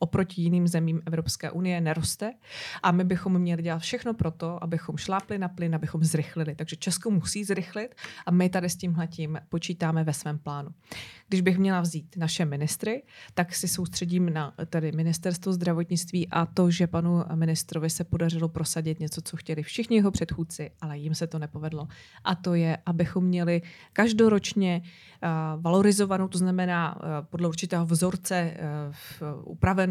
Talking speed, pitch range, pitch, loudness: 165 wpm, 160-180 Hz, 170 Hz, -27 LUFS